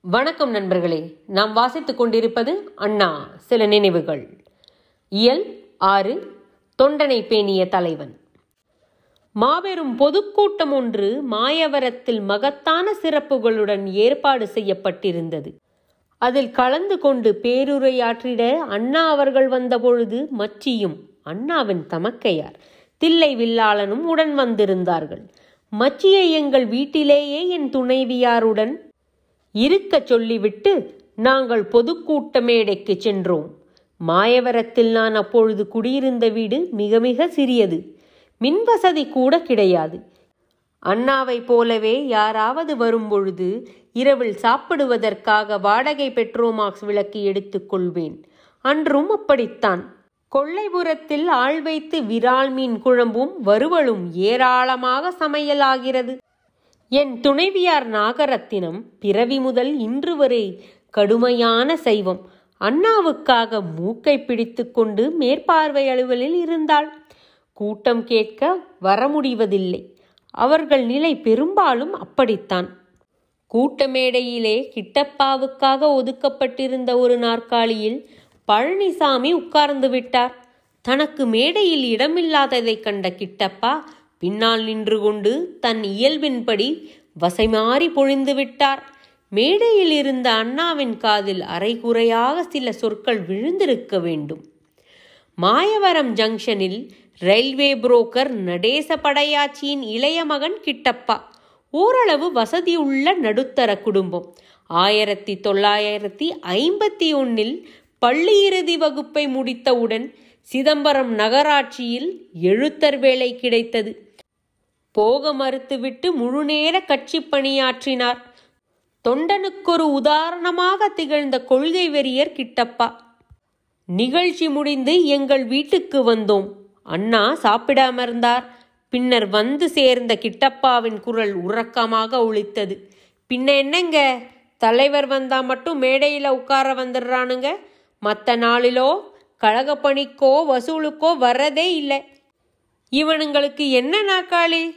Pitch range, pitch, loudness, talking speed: 220-290 Hz, 255 Hz, -19 LUFS, 80 wpm